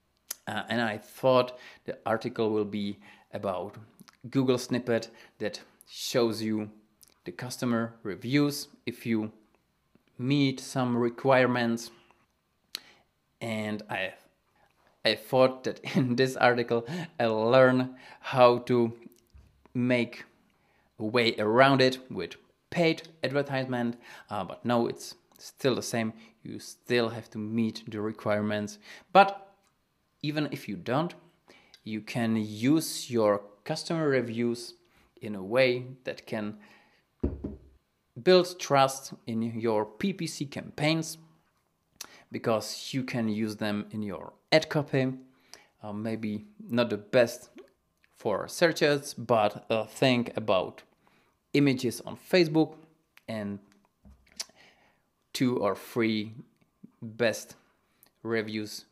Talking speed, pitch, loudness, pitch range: 110 wpm, 120 Hz, -29 LUFS, 110-135 Hz